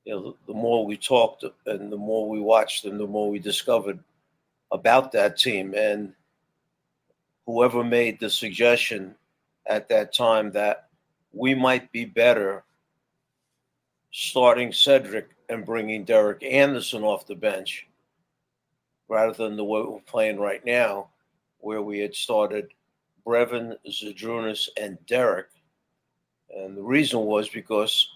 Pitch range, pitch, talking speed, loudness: 105-115 Hz, 110 Hz, 130 wpm, -23 LUFS